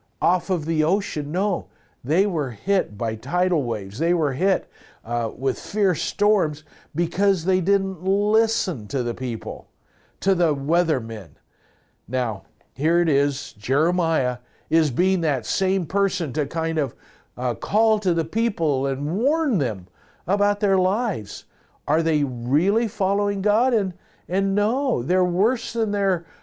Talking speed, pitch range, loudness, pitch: 145 wpm, 140-195 Hz, -23 LUFS, 175 Hz